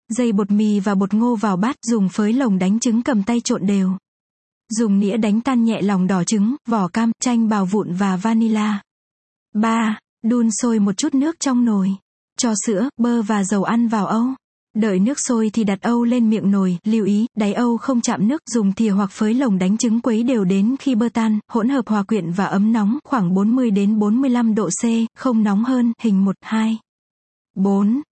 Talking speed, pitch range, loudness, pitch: 205 wpm, 205-235 Hz, -18 LUFS, 220 Hz